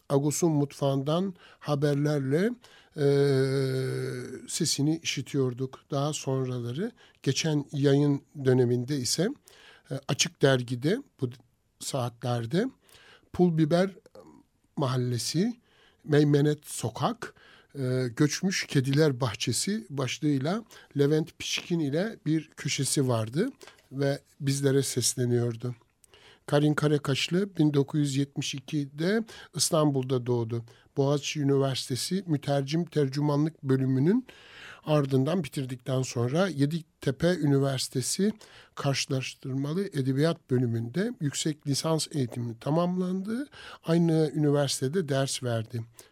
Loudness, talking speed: -28 LUFS, 80 wpm